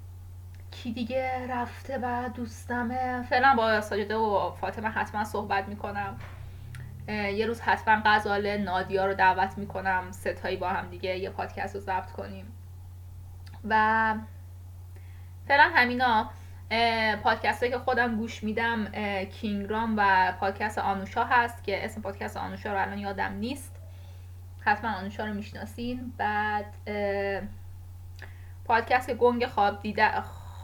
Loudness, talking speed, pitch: -28 LUFS, 120 wpm, 190 Hz